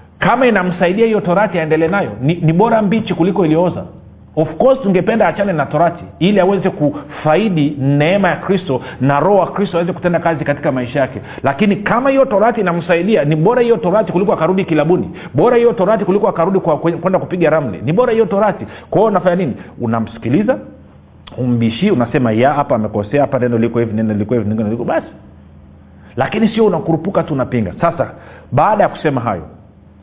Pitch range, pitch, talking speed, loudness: 130-195 Hz, 165 Hz, 155 wpm, -14 LUFS